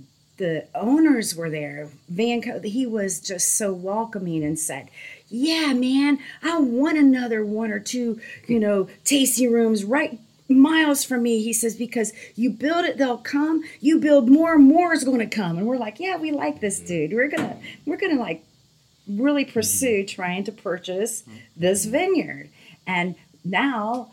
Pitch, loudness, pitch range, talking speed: 230 Hz, -21 LUFS, 185-275 Hz, 170 wpm